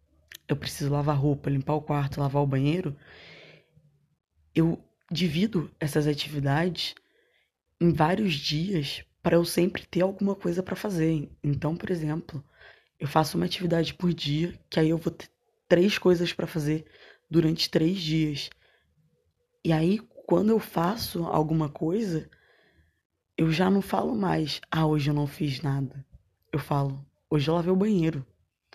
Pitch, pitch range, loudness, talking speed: 160 Hz, 145-175 Hz, -27 LUFS, 150 wpm